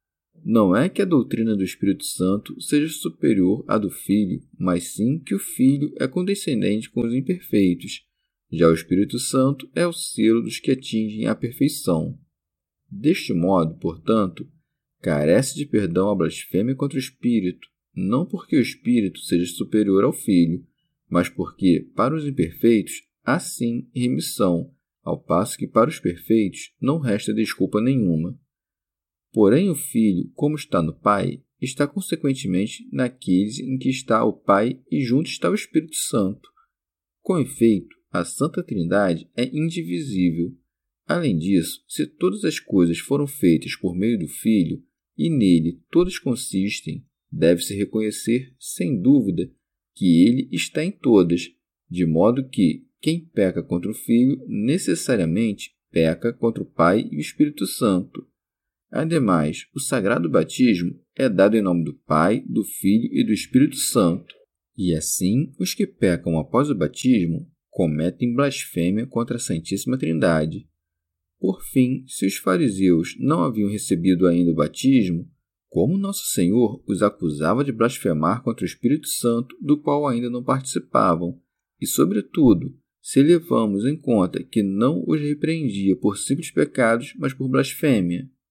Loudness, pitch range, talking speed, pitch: -21 LUFS, 90-135 Hz, 145 wpm, 110 Hz